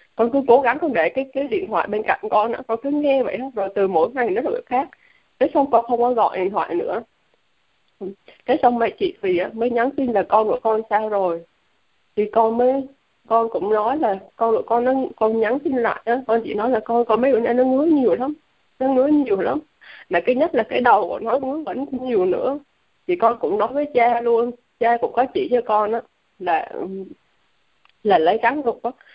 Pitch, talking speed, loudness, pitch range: 240 Hz, 235 wpm, -20 LUFS, 220-270 Hz